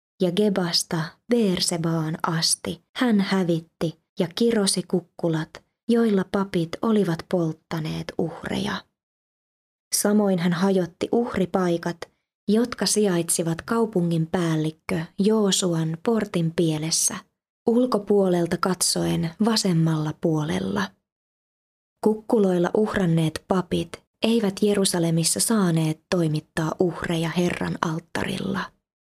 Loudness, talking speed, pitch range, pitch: -23 LUFS, 80 wpm, 165-205 Hz, 180 Hz